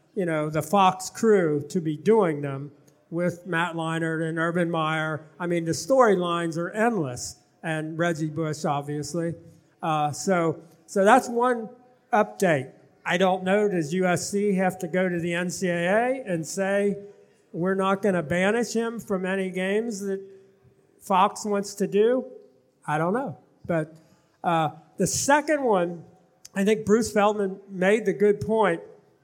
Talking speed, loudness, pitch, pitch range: 150 wpm, -25 LUFS, 185 Hz, 165-200 Hz